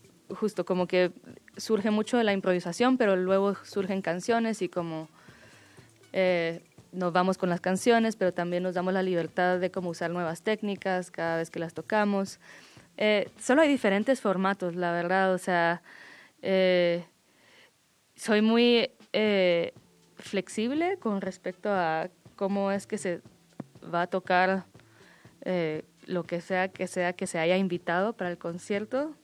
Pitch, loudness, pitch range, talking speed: 185 Hz, -28 LUFS, 175-200 Hz, 150 wpm